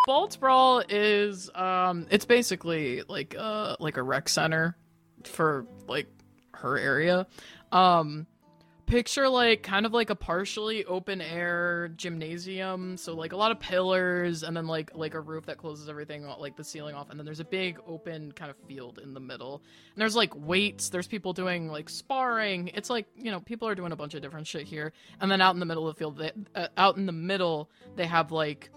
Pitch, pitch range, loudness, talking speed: 175 Hz, 155-200 Hz, -28 LUFS, 200 wpm